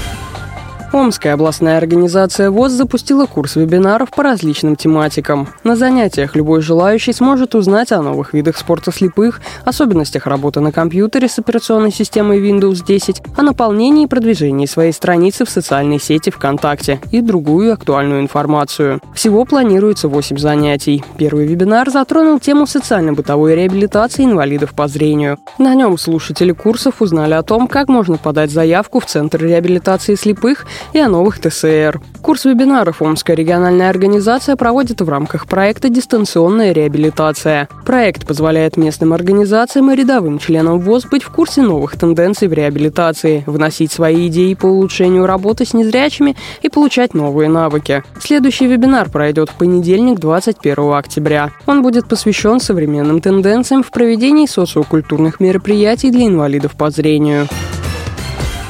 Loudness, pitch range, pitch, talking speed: -12 LUFS, 155-230 Hz, 180 Hz, 135 wpm